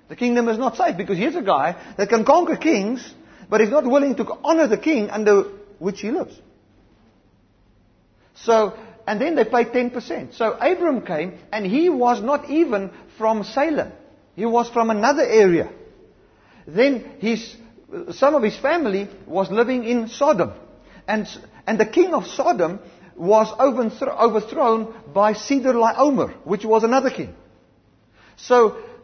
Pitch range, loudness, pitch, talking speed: 195-270 Hz, -20 LUFS, 225 Hz, 150 wpm